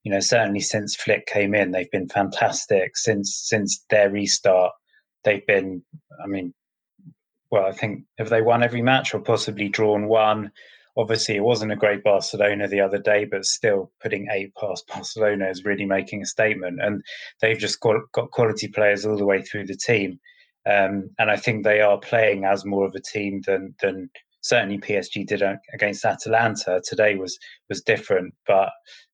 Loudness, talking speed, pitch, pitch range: -22 LUFS, 180 wpm, 105 Hz, 100-110 Hz